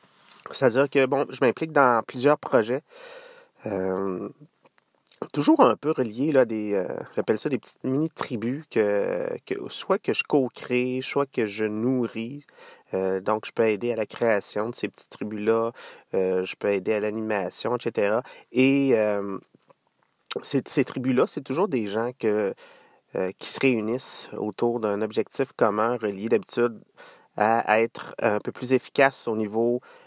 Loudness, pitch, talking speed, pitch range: -25 LUFS, 120 Hz, 160 wpm, 105-140 Hz